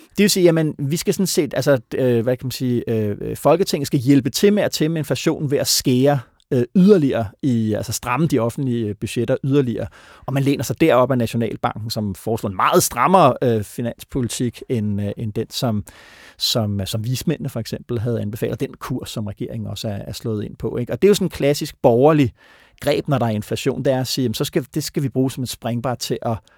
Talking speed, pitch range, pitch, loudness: 230 wpm, 115-145 Hz, 125 Hz, -20 LUFS